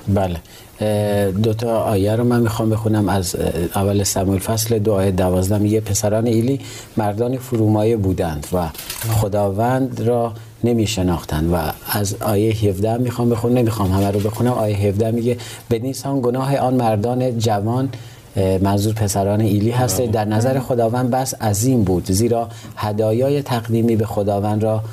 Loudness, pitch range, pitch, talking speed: -19 LUFS, 100-120 Hz, 110 Hz, 140 wpm